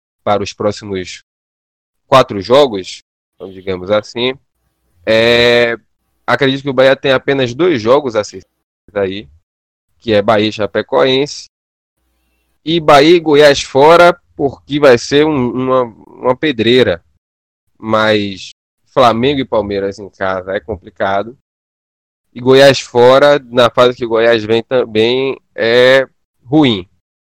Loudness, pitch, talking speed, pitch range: -12 LUFS, 110 Hz, 120 wpm, 90-130 Hz